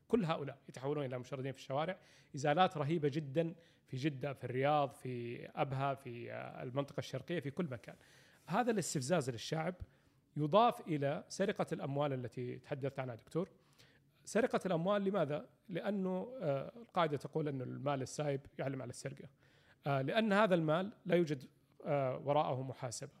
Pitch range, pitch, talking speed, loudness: 135-170 Hz, 145 Hz, 135 wpm, -38 LUFS